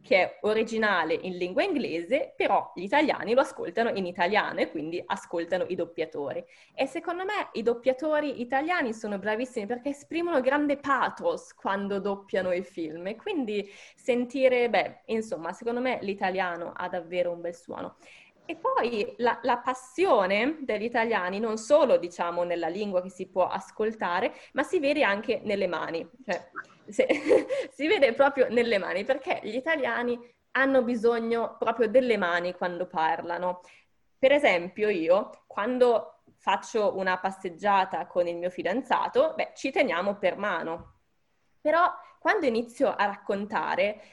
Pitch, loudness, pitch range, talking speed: 230 Hz, -27 LUFS, 185-270 Hz, 145 wpm